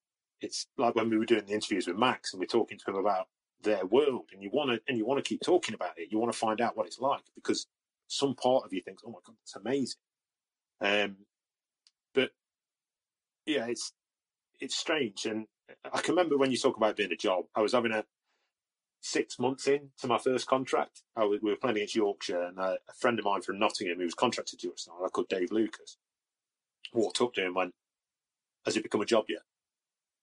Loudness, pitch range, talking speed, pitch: -31 LUFS, 105-135 Hz, 225 wpm, 115 Hz